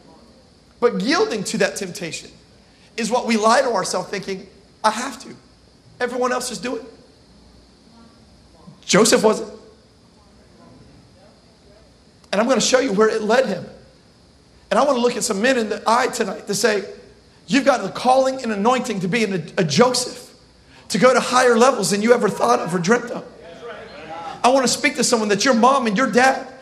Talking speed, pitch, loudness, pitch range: 185 wpm, 235 Hz, -18 LUFS, 215-250 Hz